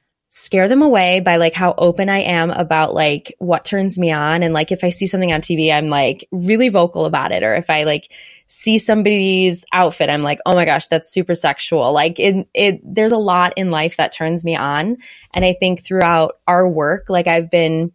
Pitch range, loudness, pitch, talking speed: 165-190 Hz, -15 LUFS, 175 Hz, 220 wpm